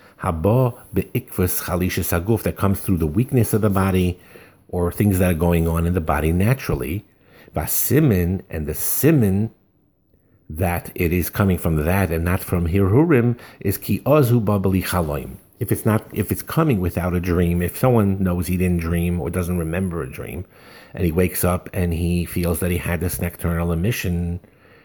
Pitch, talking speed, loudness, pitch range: 90 Hz, 160 wpm, -20 LUFS, 85-105 Hz